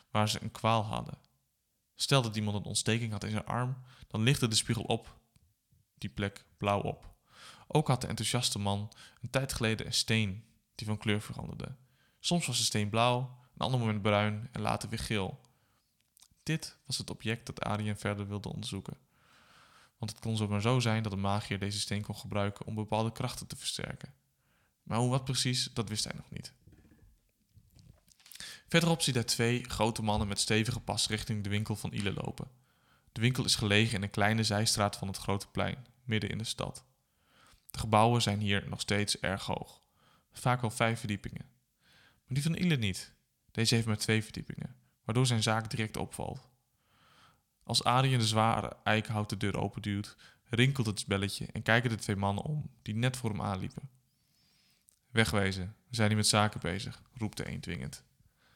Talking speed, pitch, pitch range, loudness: 180 wpm, 110 Hz, 105-125 Hz, -32 LUFS